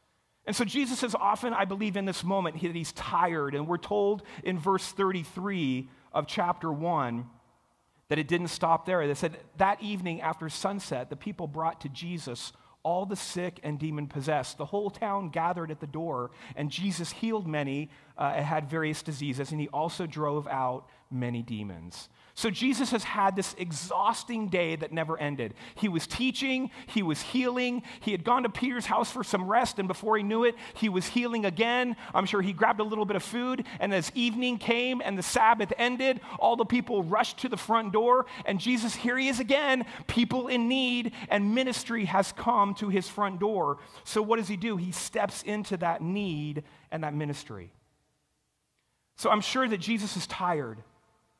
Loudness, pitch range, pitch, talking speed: -29 LUFS, 155-225 Hz, 195 Hz, 190 wpm